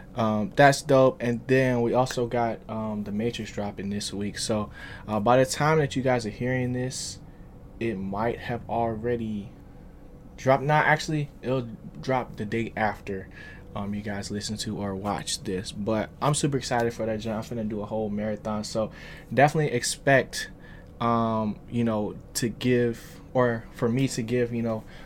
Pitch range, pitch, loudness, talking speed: 105-125 Hz, 115 Hz, -26 LUFS, 170 wpm